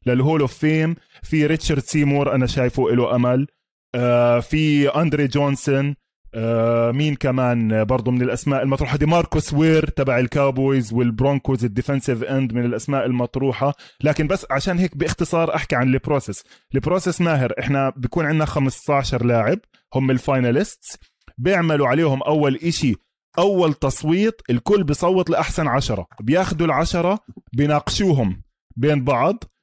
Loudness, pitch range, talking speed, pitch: -20 LUFS, 125-155 Hz, 125 wpm, 140 Hz